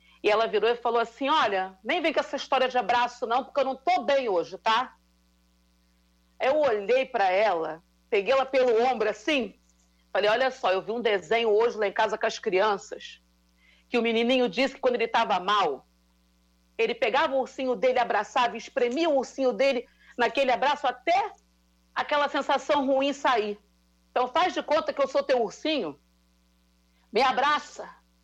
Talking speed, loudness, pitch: 175 wpm, -26 LUFS, 235 Hz